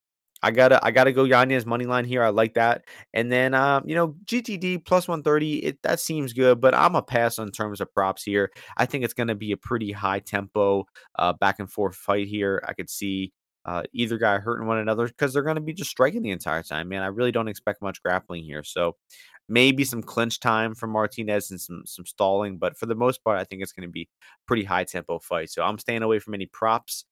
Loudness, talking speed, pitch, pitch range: -24 LUFS, 250 wpm, 110 Hz, 100-130 Hz